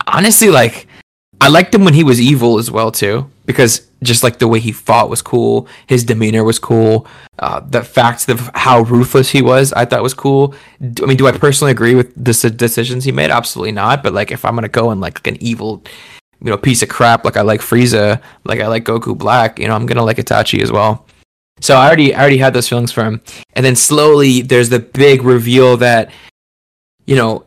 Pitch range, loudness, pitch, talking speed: 115-130 Hz, -11 LUFS, 120 Hz, 225 wpm